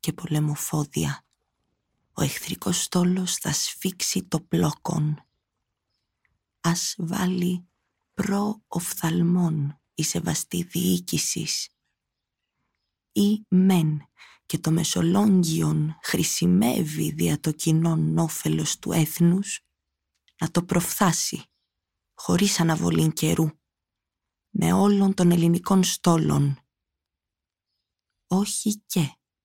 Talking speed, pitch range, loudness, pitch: 80 wpm, 145-180 Hz, -24 LUFS, 165 Hz